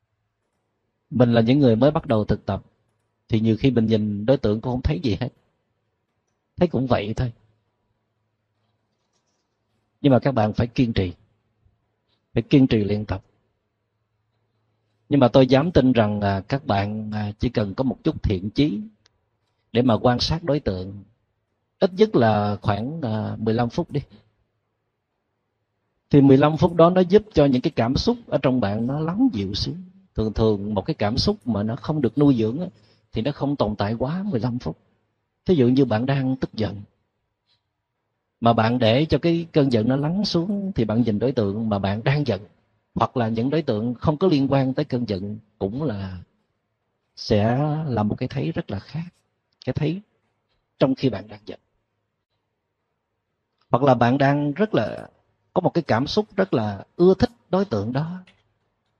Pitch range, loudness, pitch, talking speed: 105-135 Hz, -22 LUFS, 115 Hz, 180 wpm